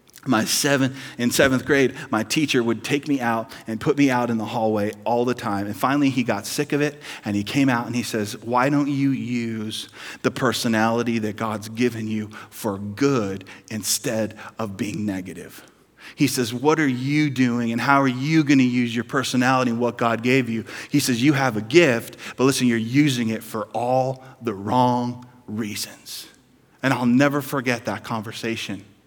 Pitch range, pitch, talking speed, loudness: 110-135 Hz, 120 Hz, 190 wpm, -22 LUFS